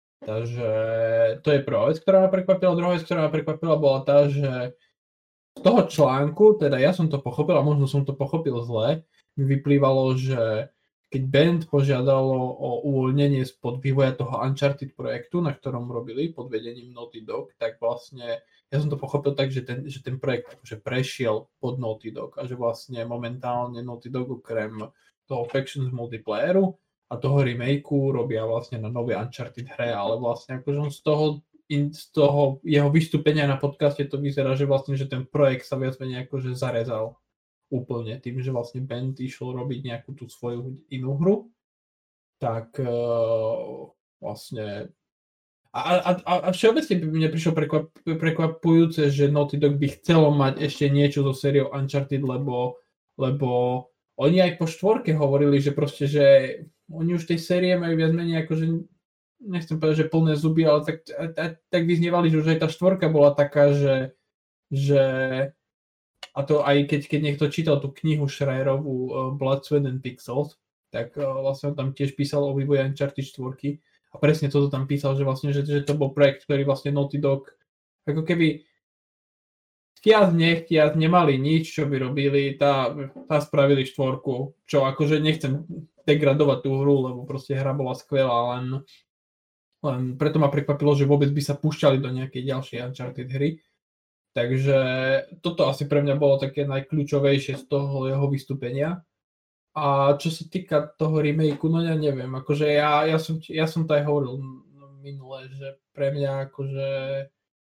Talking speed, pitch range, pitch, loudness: 165 wpm, 130-150 Hz, 140 Hz, -23 LUFS